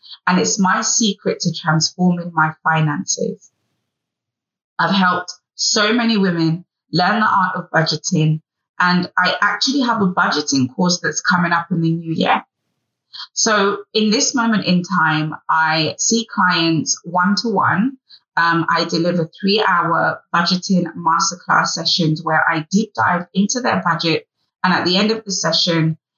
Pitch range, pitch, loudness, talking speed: 165-200 Hz, 180 Hz, -17 LUFS, 150 wpm